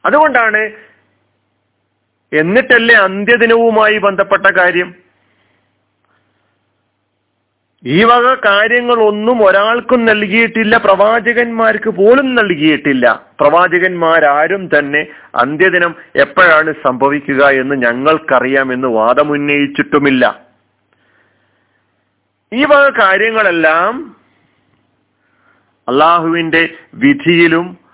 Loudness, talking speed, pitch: -10 LUFS, 60 wpm, 165 Hz